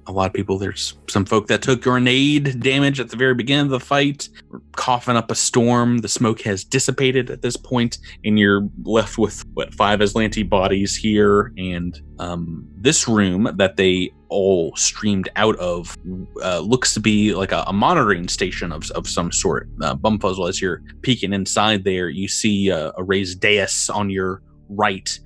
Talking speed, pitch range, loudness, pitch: 185 wpm, 95-120 Hz, -19 LUFS, 105 Hz